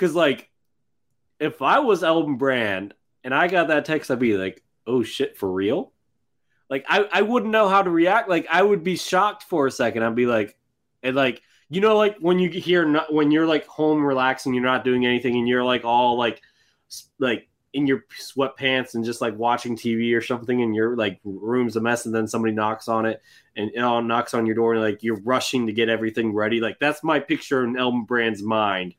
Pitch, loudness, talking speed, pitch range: 125 Hz, -22 LUFS, 225 wpm, 115-150 Hz